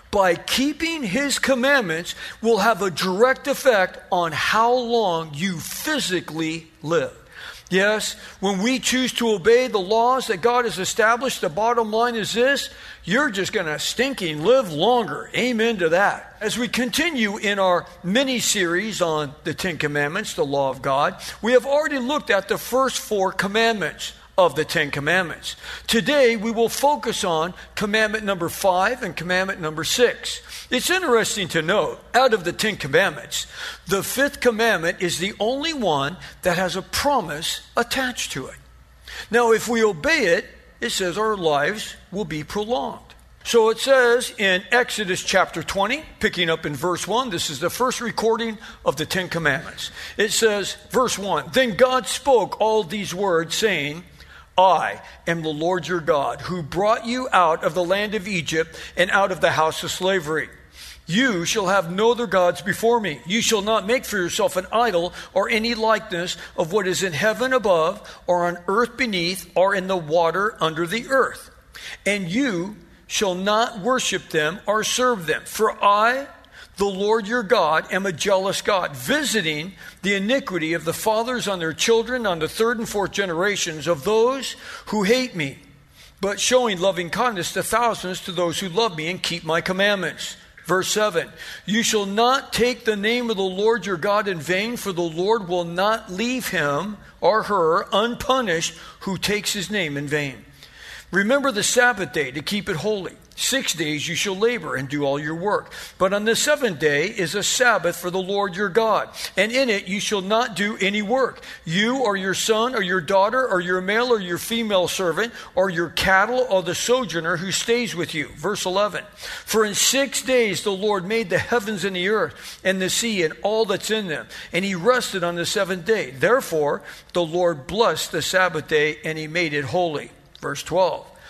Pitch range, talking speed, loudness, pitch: 175-230 Hz, 180 wpm, -21 LUFS, 200 Hz